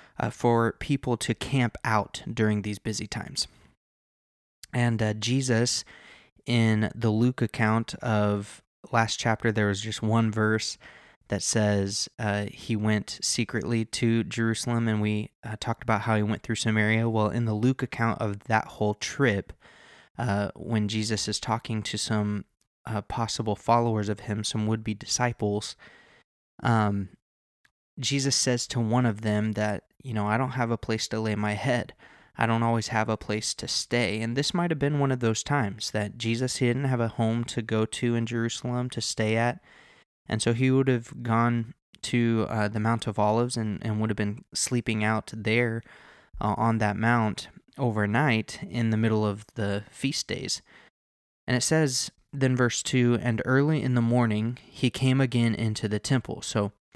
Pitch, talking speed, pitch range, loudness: 115 Hz, 180 wpm, 105-120 Hz, -27 LUFS